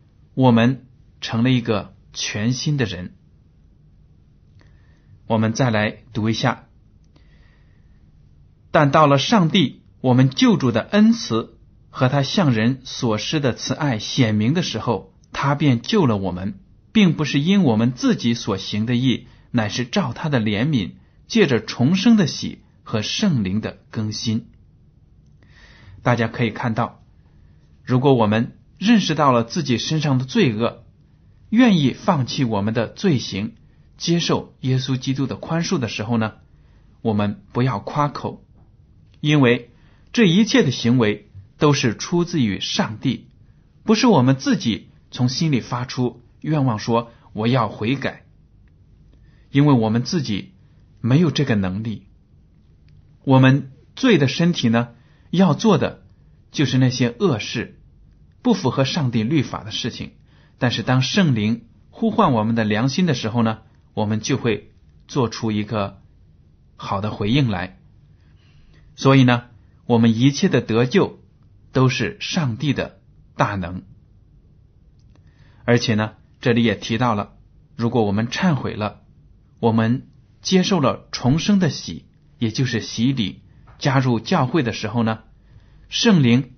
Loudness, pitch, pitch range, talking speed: -20 LUFS, 120 Hz, 110-140 Hz, 200 characters per minute